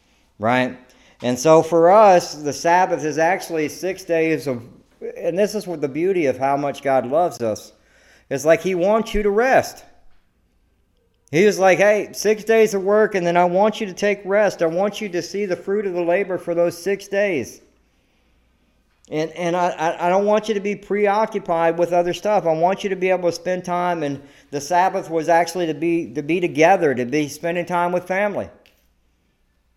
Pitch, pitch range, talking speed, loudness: 175 Hz, 155-200 Hz, 200 wpm, -19 LUFS